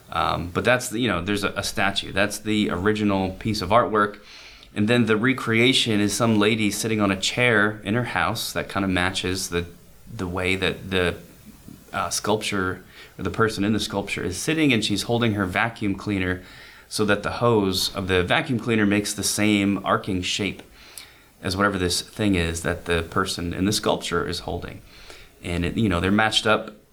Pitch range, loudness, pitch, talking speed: 95-110 Hz, -22 LUFS, 100 Hz, 195 wpm